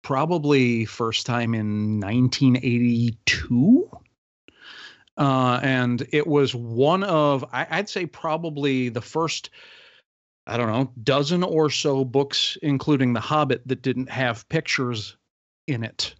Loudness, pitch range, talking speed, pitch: -22 LUFS, 120-150 Hz, 120 wpm, 130 Hz